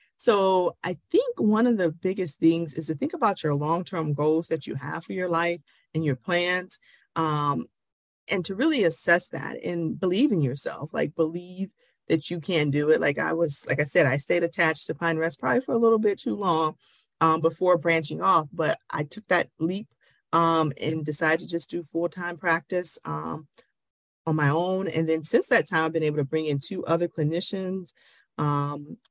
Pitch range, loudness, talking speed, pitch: 155-180 Hz, -25 LUFS, 200 wpm, 165 Hz